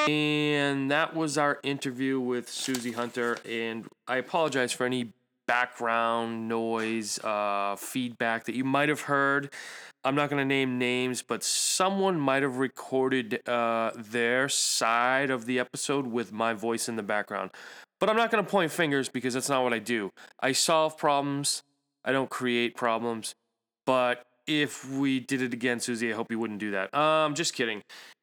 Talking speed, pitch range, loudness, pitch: 170 wpm, 115-140 Hz, -28 LUFS, 125 Hz